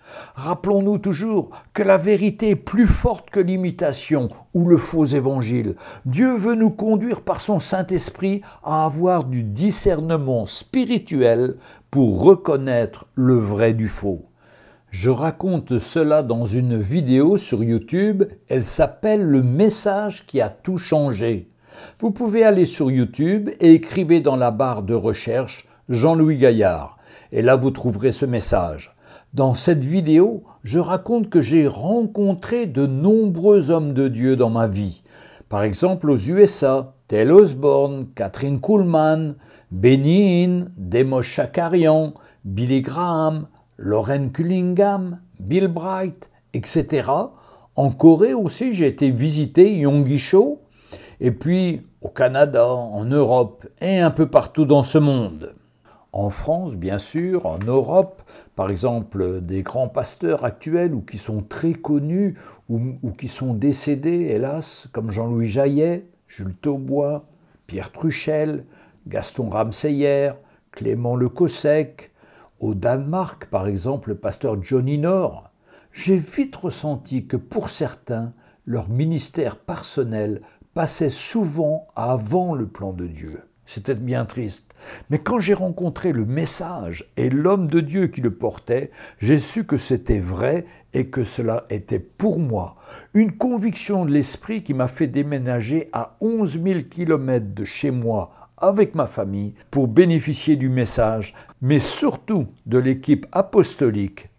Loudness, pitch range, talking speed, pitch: -20 LUFS, 120-175 Hz, 135 wpm, 145 Hz